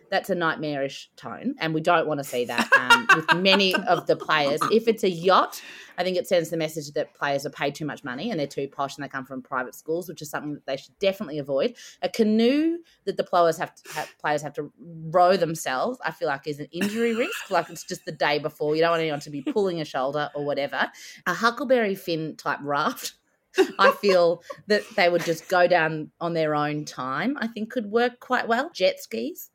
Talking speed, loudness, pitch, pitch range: 230 wpm, -24 LUFS, 165 Hz, 150-195 Hz